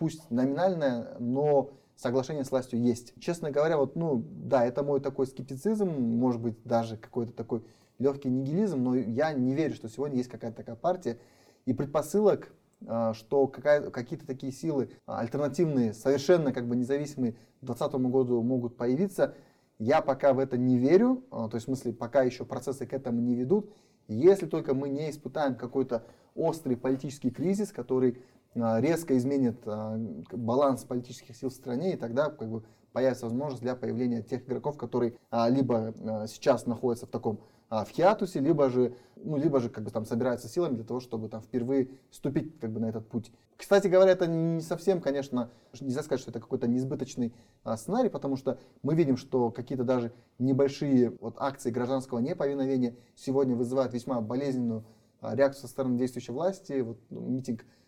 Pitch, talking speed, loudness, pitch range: 125 Hz, 170 wpm, -30 LUFS, 120-140 Hz